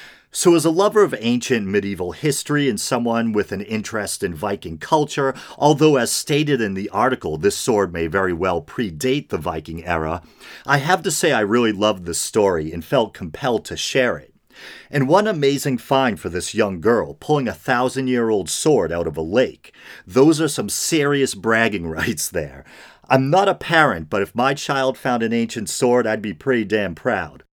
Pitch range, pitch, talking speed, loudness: 100-140 Hz, 125 Hz, 190 wpm, -19 LUFS